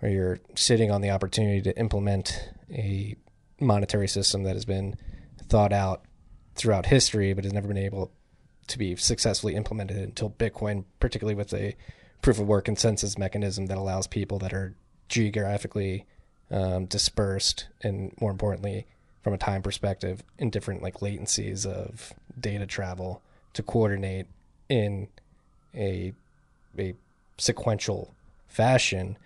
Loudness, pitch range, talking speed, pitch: -28 LUFS, 95-105 Hz, 135 wpm, 100 Hz